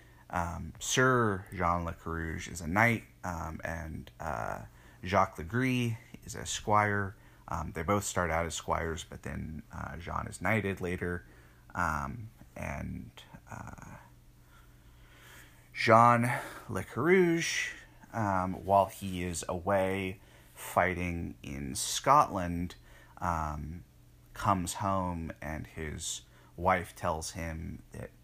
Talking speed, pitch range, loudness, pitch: 115 wpm, 80-100 Hz, -32 LUFS, 90 Hz